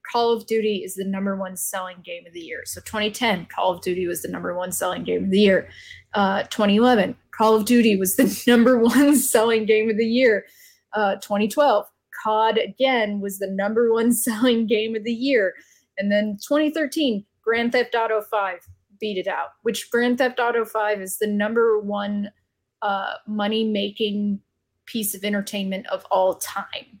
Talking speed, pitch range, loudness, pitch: 180 wpm, 195-235 Hz, -21 LUFS, 215 Hz